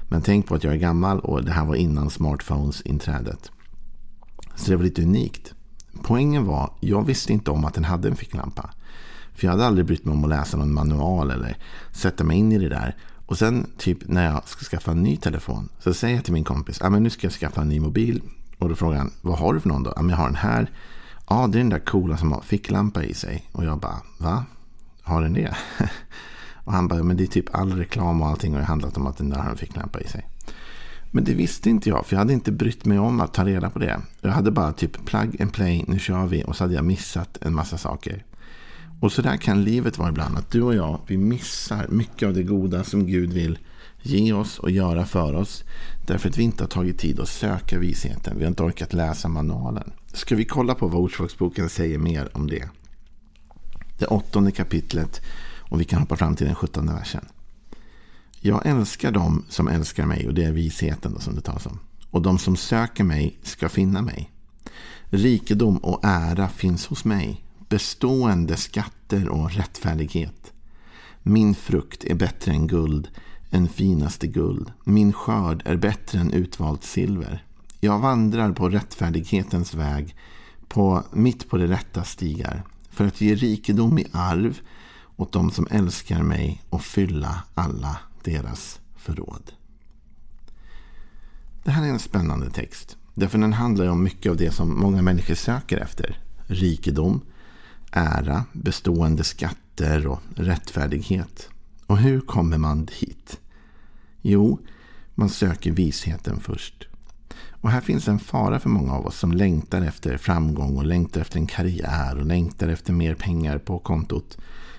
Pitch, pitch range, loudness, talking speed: 90 Hz, 80-100 Hz, -23 LUFS, 190 wpm